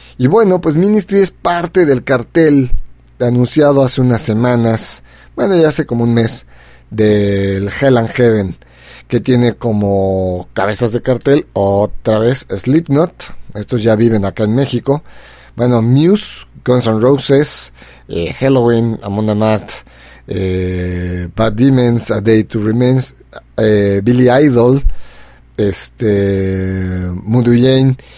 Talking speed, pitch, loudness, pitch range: 125 wpm, 115 Hz, -13 LUFS, 100-130 Hz